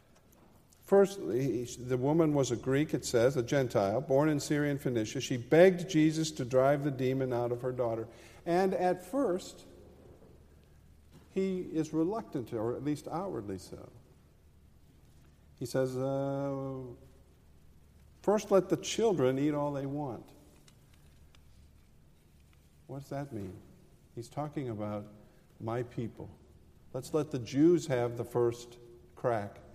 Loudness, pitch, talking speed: -32 LUFS, 125 Hz, 130 wpm